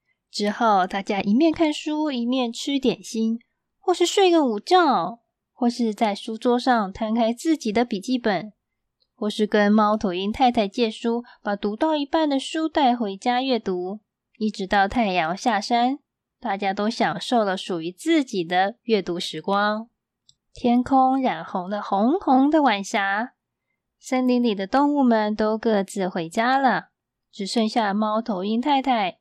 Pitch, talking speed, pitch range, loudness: 230 Hz, 220 characters per minute, 205-260 Hz, -22 LUFS